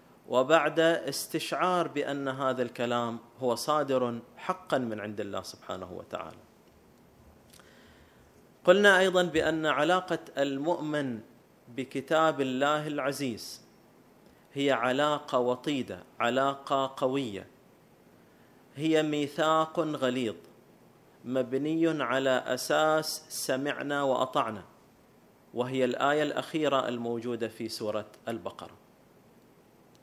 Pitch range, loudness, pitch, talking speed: 120-155 Hz, -29 LUFS, 135 Hz, 80 wpm